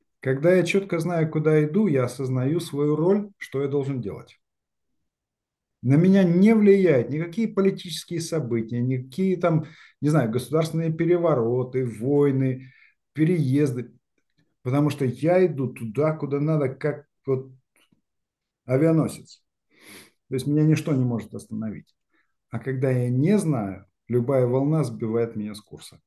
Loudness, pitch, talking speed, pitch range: -23 LUFS, 145 Hz, 130 wpm, 125-165 Hz